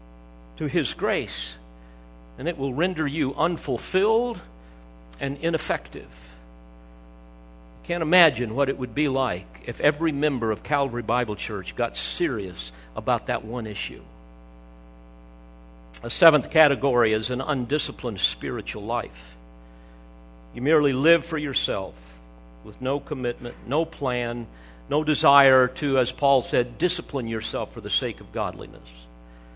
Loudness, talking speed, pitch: -24 LUFS, 125 wpm, 110 Hz